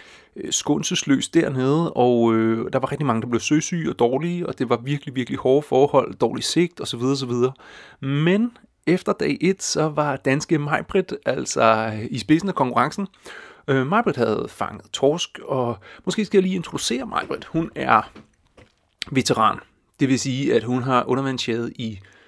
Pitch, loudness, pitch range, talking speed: 135 Hz, -22 LUFS, 125-165 Hz, 160 wpm